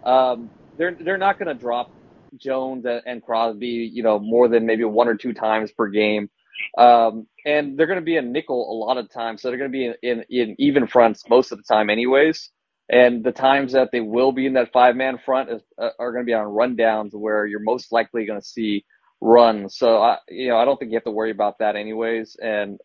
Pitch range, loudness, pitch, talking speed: 110-130 Hz, -20 LUFS, 120 Hz, 240 wpm